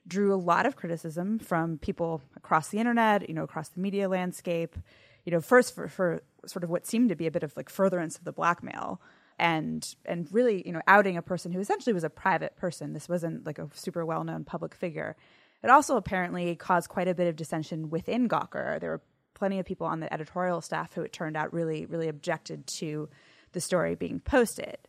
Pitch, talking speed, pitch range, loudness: 175 Hz, 215 wpm, 160-195 Hz, -29 LUFS